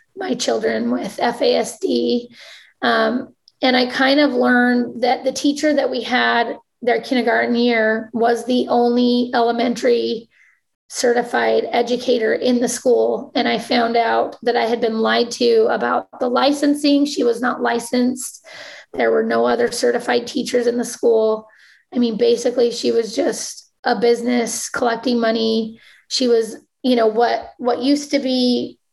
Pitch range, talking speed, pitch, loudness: 230-255 Hz, 150 wpm, 240 Hz, -18 LUFS